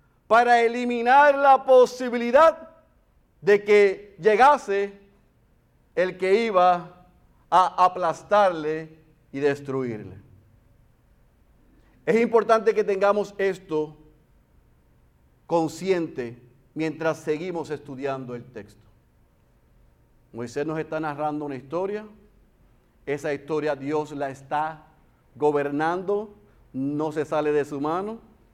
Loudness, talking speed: -23 LUFS, 90 wpm